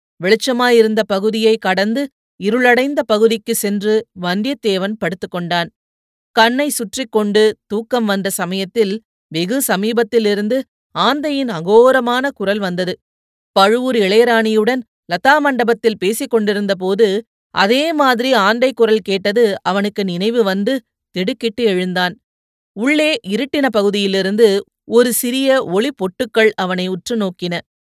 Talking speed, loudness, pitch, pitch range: 95 wpm, -16 LUFS, 220 Hz, 195-245 Hz